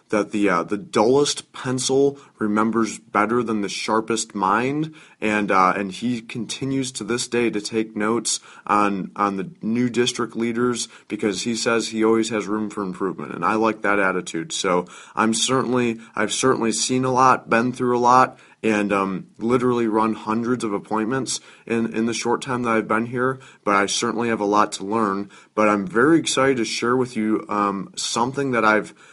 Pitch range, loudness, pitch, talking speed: 105-125 Hz, -21 LUFS, 115 Hz, 185 wpm